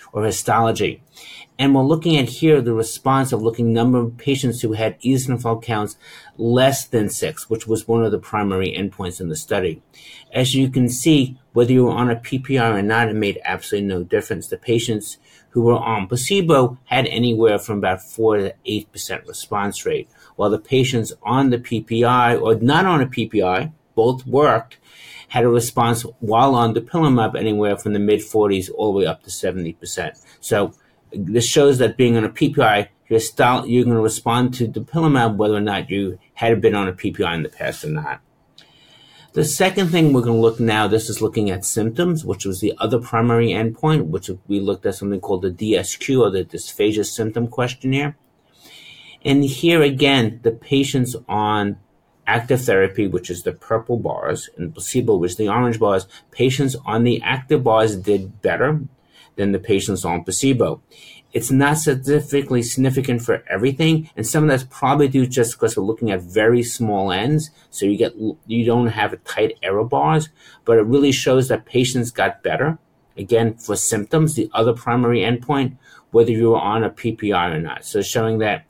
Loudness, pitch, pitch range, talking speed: -19 LUFS, 115 Hz, 110-135 Hz, 185 wpm